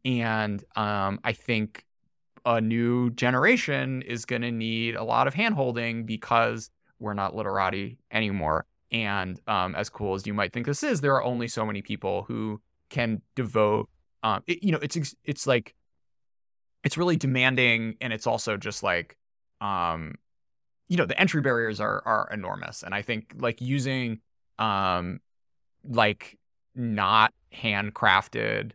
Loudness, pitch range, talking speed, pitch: -27 LUFS, 105-130 Hz, 150 wpm, 115 Hz